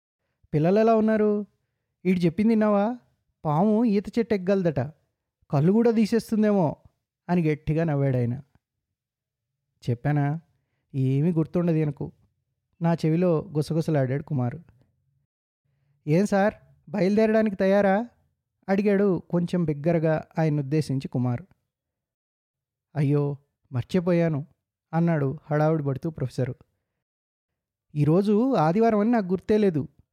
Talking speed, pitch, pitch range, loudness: 90 wpm, 155 Hz, 135-195 Hz, -24 LUFS